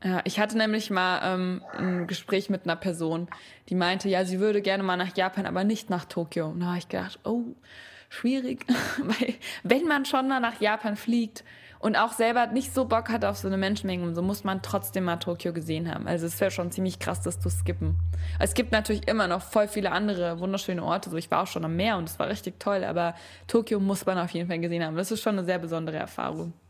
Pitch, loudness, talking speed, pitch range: 185 Hz, -28 LUFS, 235 wpm, 170-215 Hz